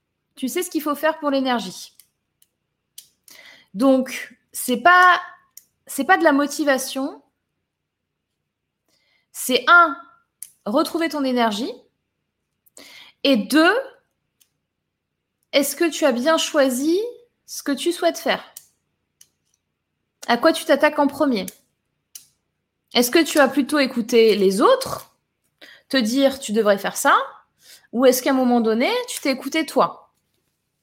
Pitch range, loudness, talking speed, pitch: 255-330 Hz, -19 LUFS, 125 wpm, 285 Hz